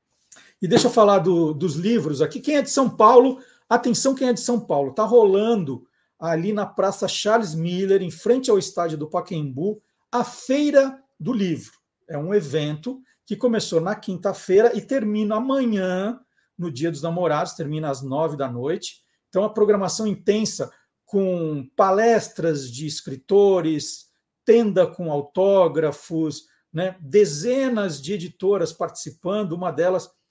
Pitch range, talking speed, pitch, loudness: 165-220 Hz, 145 wpm, 195 Hz, -21 LUFS